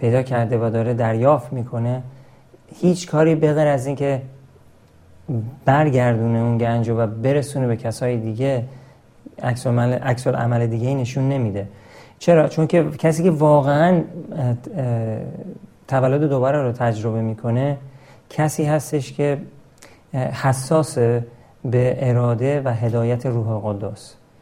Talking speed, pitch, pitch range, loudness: 120 wpm, 130 Hz, 120-140 Hz, -20 LUFS